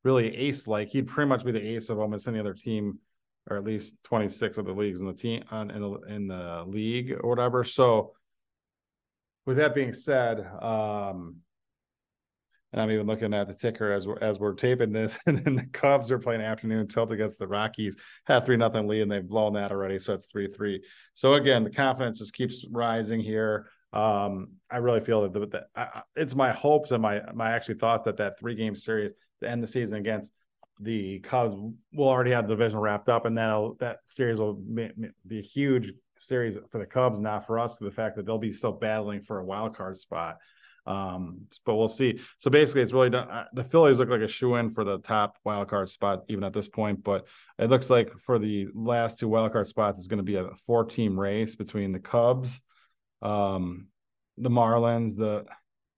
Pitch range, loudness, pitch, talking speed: 105-120 Hz, -28 LUFS, 110 Hz, 210 wpm